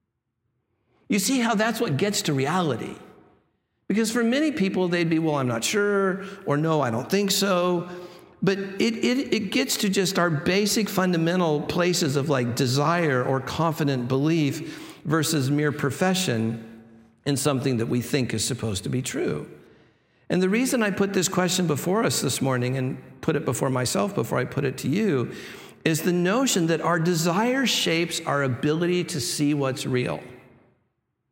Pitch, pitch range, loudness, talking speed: 165 Hz, 135-190 Hz, -24 LUFS, 170 wpm